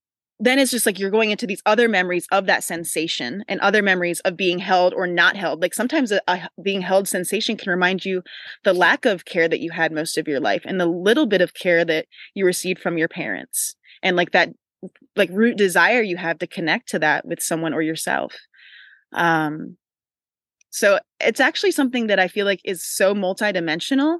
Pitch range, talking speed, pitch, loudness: 170-210 Hz, 205 wpm, 185 Hz, -20 LUFS